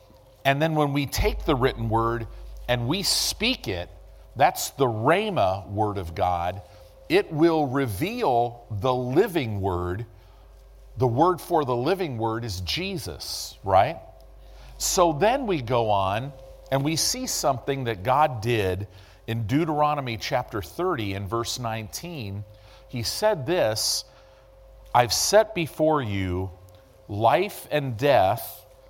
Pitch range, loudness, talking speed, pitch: 100-145 Hz, -24 LUFS, 130 wpm, 115 Hz